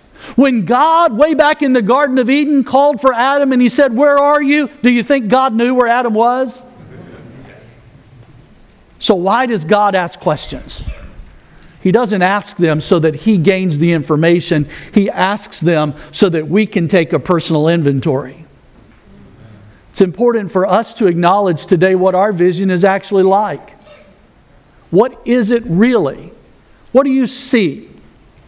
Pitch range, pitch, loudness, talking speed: 165-250 Hz, 200 Hz, -13 LUFS, 155 wpm